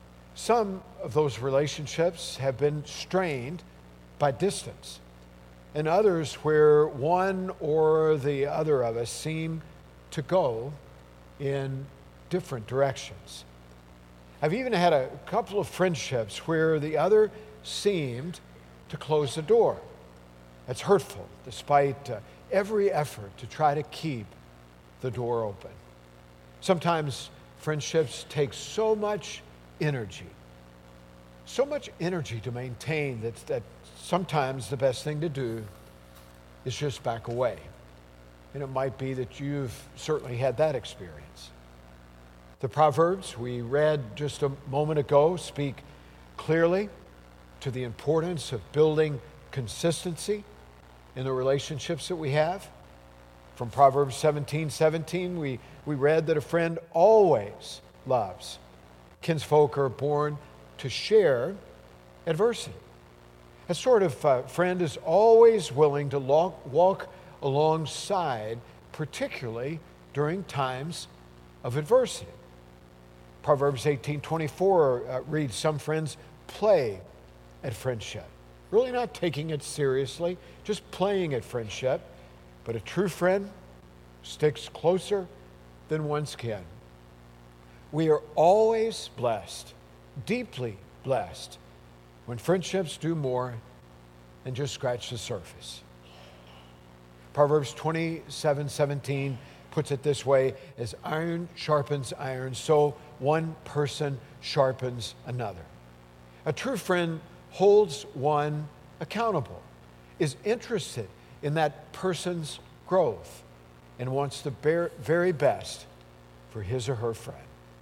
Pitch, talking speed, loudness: 140 Hz, 110 wpm, -28 LUFS